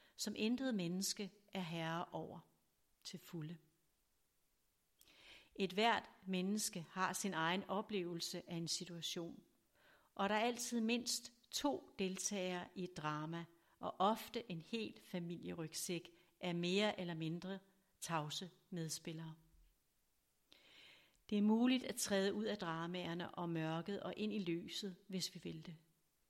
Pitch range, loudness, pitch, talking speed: 170-205 Hz, -42 LUFS, 180 Hz, 130 wpm